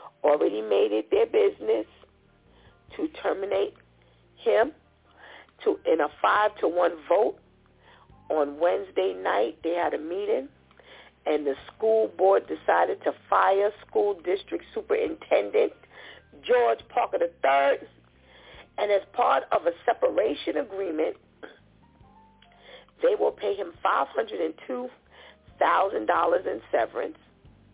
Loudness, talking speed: -26 LUFS, 105 wpm